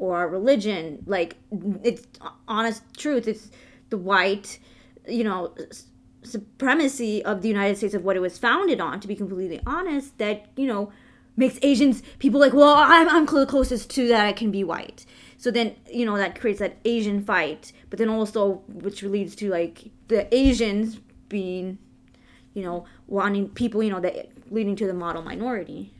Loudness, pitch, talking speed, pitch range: -23 LUFS, 215 Hz, 170 wpm, 195-245 Hz